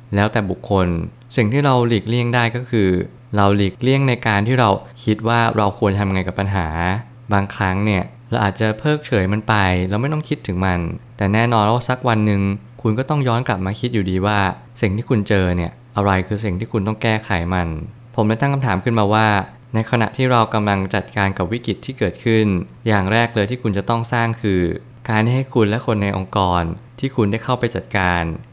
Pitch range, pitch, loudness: 100-120 Hz, 110 Hz, -19 LUFS